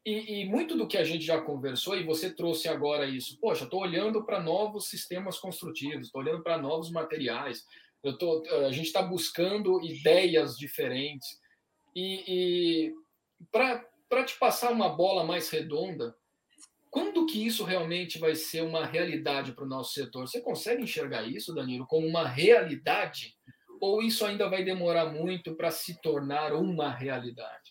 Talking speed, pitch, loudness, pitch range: 160 wpm, 165 Hz, -30 LUFS, 155-195 Hz